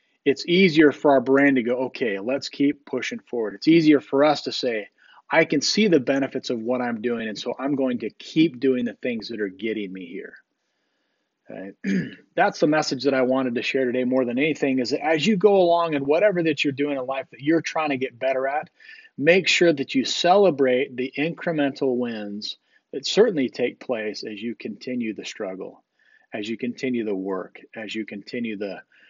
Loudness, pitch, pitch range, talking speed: -22 LUFS, 135 Hz, 120-155 Hz, 205 wpm